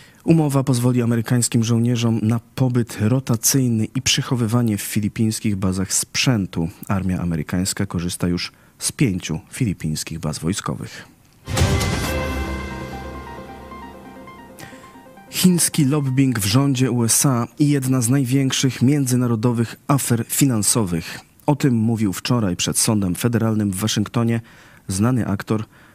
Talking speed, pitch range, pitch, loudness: 105 wpm, 95-130 Hz, 115 Hz, -20 LUFS